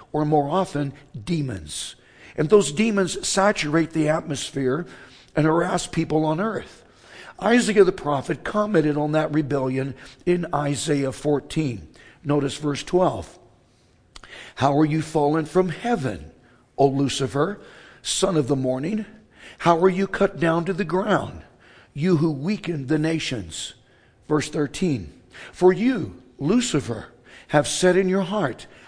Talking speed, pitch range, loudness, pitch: 130 wpm, 140-180 Hz, -22 LUFS, 155 Hz